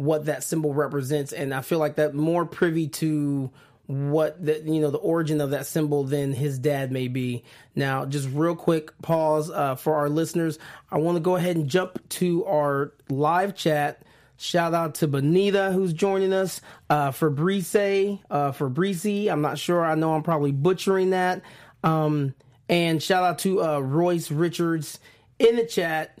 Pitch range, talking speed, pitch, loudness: 145-175 Hz, 180 wpm, 155 Hz, -24 LUFS